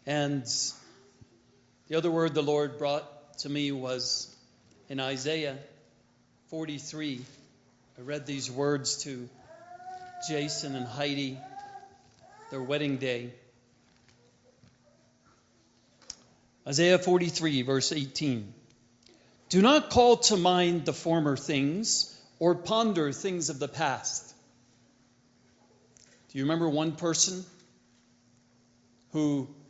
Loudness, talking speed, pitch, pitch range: -28 LUFS, 95 wpm, 145 Hz, 130-165 Hz